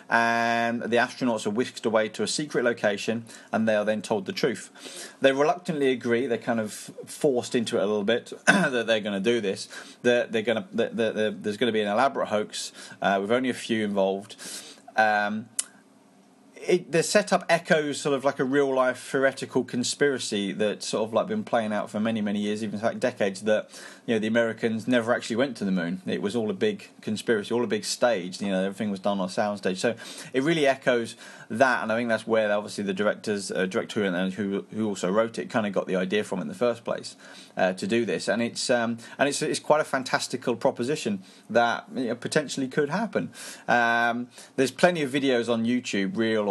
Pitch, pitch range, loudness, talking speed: 120 Hz, 110-140 Hz, -26 LUFS, 225 wpm